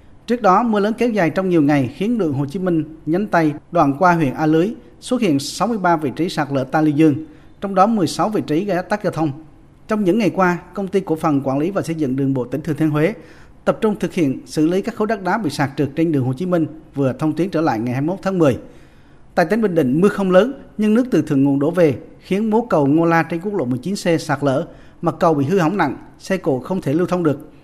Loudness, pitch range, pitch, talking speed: -18 LUFS, 150-190 Hz, 165 Hz, 270 wpm